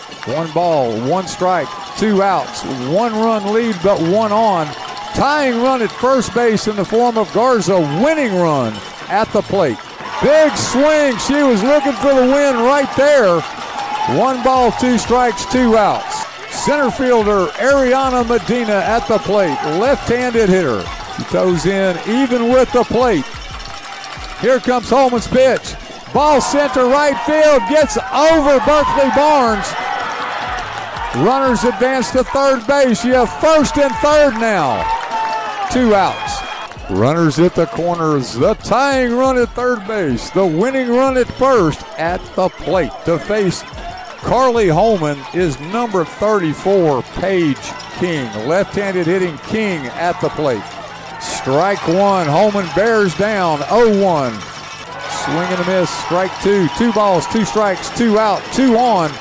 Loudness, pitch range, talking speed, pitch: -15 LUFS, 190-260 Hz, 140 wpm, 225 Hz